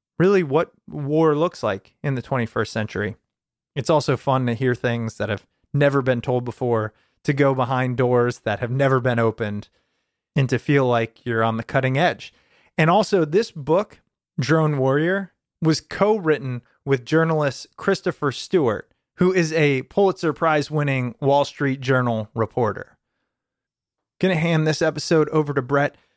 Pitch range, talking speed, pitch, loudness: 120-155 Hz, 160 wpm, 140 Hz, -21 LUFS